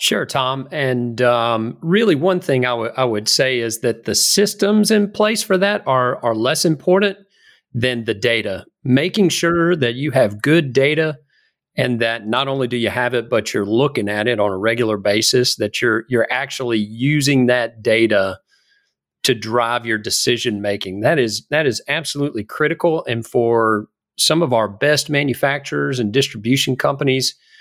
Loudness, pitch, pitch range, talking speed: -17 LUFS, 130 Hz, 115-155 Hz, 170 wpm